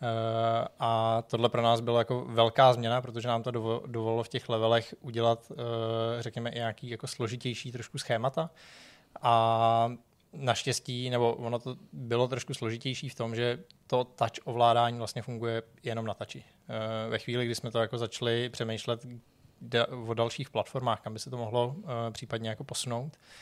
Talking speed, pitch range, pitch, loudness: 165 wpm, 115-125 Hz, 120 Hz, -31 LUFS